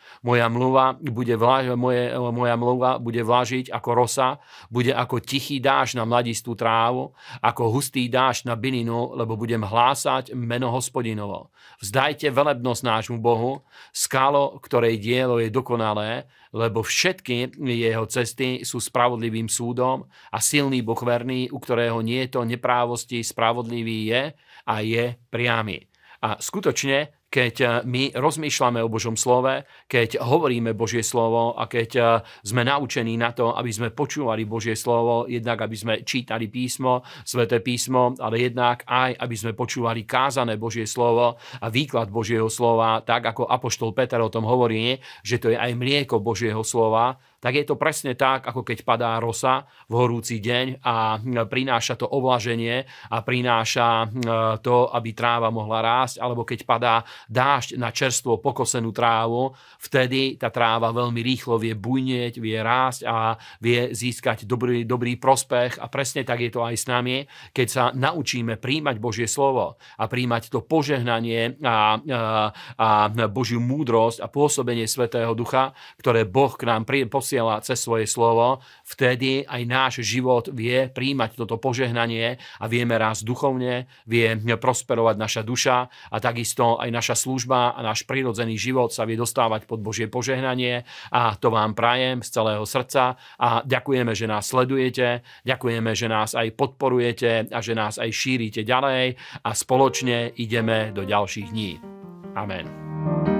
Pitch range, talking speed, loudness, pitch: 115-130 Hz, 150 wpm, -23 LUFS, 120 Hz